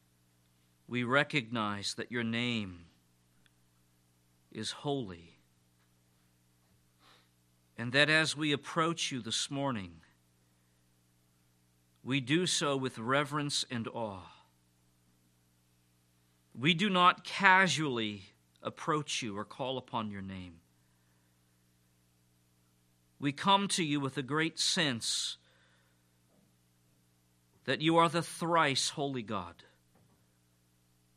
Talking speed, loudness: 90 wpm, -31 LUFS